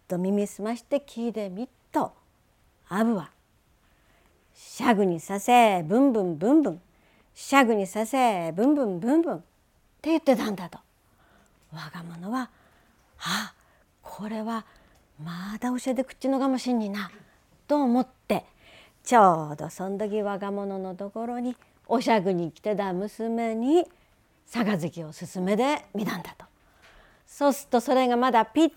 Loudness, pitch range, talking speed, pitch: -26 LUFS, 185-250 Hz, 280 characters per minute, 220 Hz